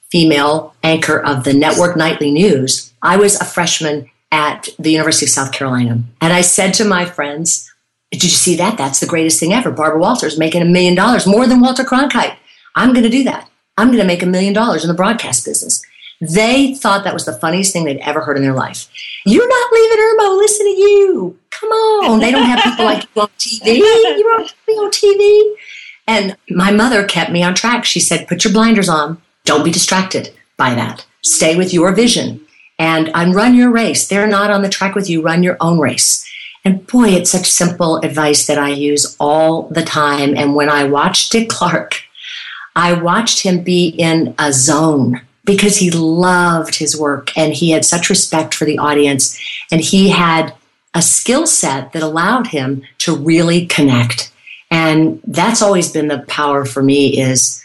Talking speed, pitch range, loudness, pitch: 195 wpm, 155-210 Hz, -12 LUFS, 175 Hz